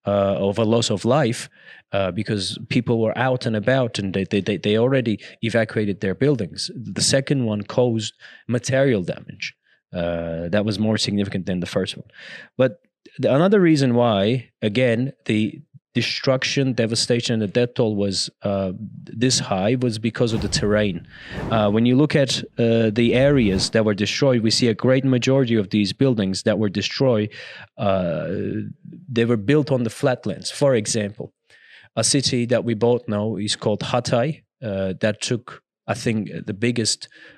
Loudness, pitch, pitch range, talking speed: -21 LUFS, 115 Hz, 105-130 Hz, 165 wpm